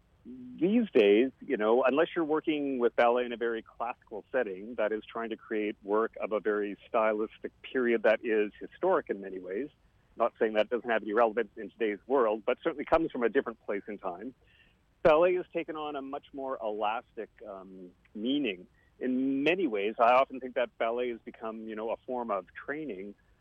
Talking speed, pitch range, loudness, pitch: 195 wpm, 110-140 Hz, -30 LUFS, 120 Hz